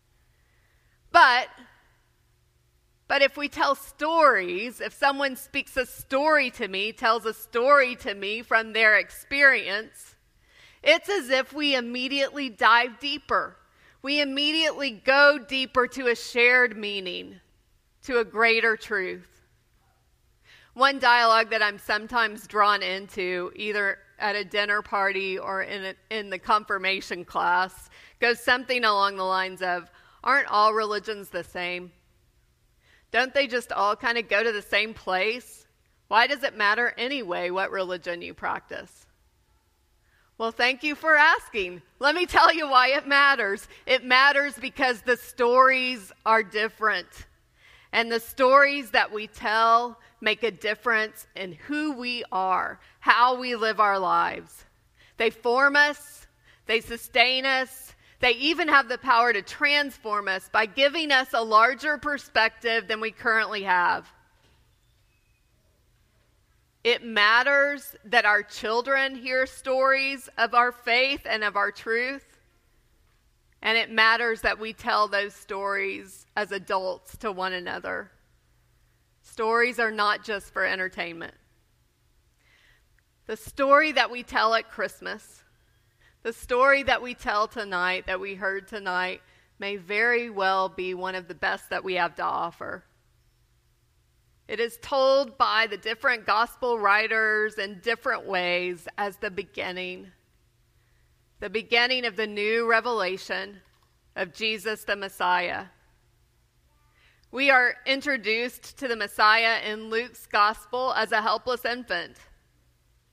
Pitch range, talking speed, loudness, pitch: 200-255 Hz, 135 wpm, -24 LUFS, 225 Hz